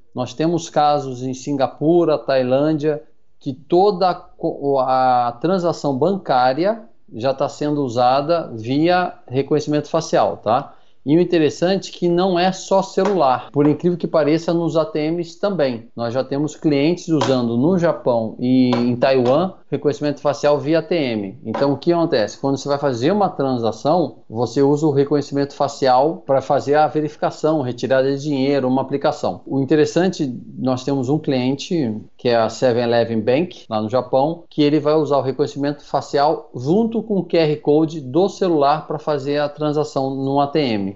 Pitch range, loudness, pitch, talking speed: 130-165 Hz, -19 LUFS, 145 Hz, 155 wpm